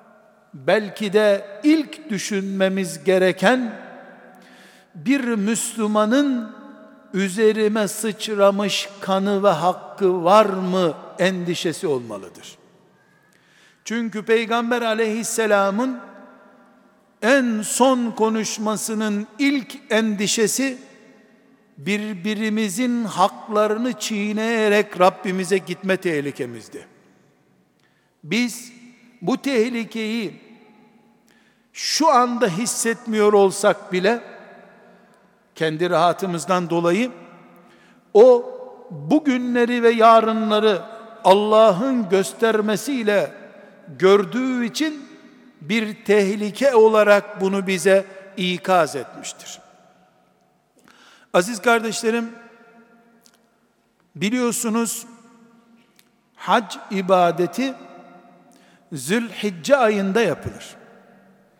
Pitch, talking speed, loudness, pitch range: 215 Hz, 60 wpm, -20 LUFS, 195-235 Hz